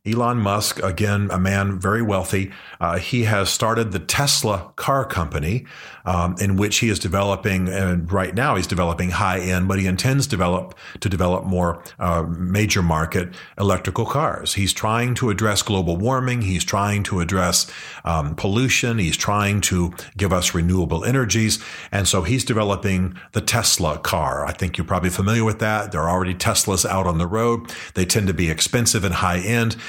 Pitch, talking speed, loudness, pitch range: 95 Hz, 180 wpm, -20 LUFS, 90-110 Hz